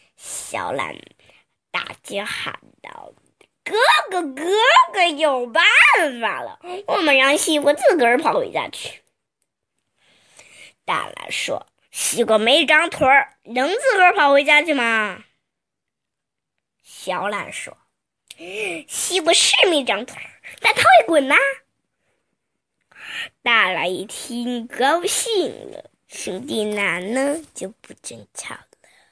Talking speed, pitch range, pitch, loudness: 150 characters per minute, 245-350 Hz, 295 Hz, -17 LUFS